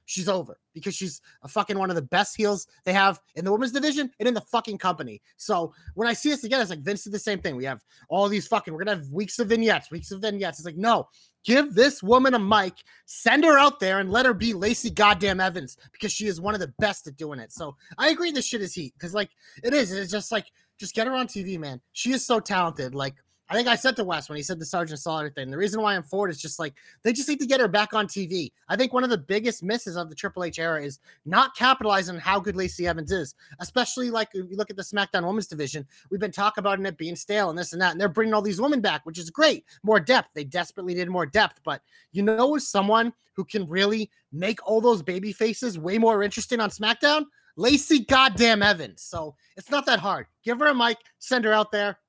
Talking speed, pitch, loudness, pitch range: 260 wpm, 205 Hz, -24 LUFS, 180-230 Hz